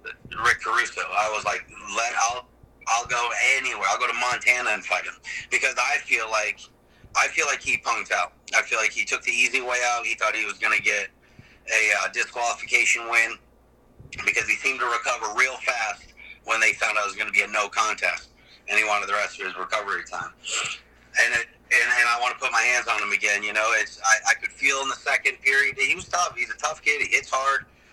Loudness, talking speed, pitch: -22 LUFS, 230 wpm, 120 Hz